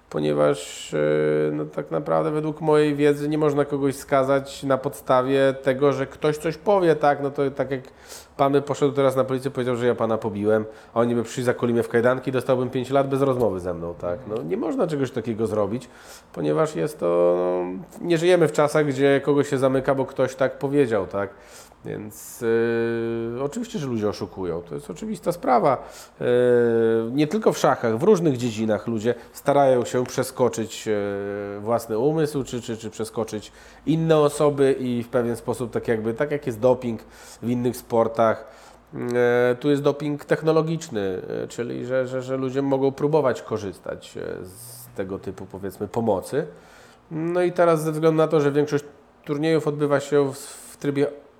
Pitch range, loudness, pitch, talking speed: 115-145 Hz, -23 LUFS, 130 Hz, 170 wpm